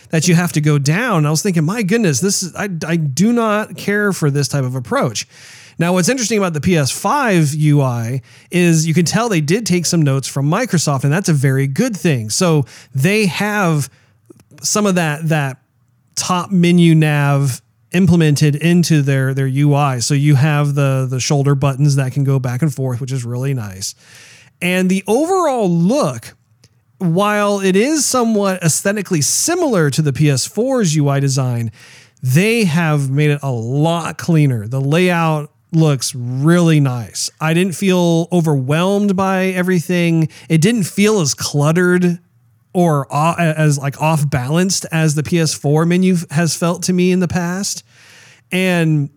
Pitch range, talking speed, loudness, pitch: 140-180 Hz, 160 wpm, -15 LUFS, 155 Hz